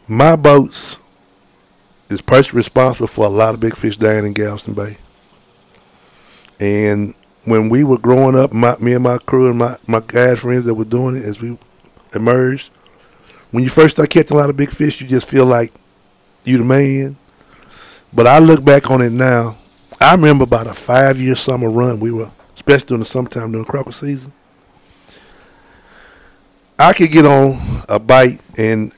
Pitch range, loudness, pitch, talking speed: 115-135 Hz, -12 LUFS, 125 Hz, 175 wpm